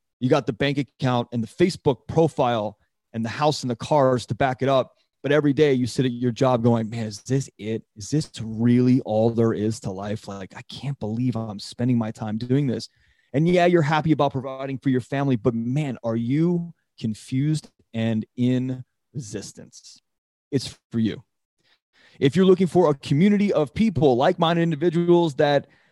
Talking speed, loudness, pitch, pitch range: 190 wpm, -23 LUFS, 130 Hz, 115-150 Hz